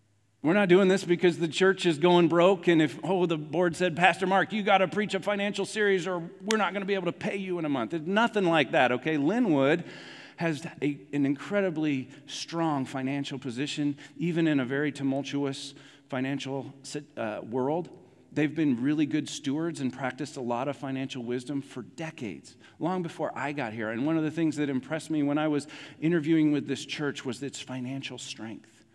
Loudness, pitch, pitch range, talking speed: -28 LUFS, 150 Hz, 140-175 Hz, 200 wpm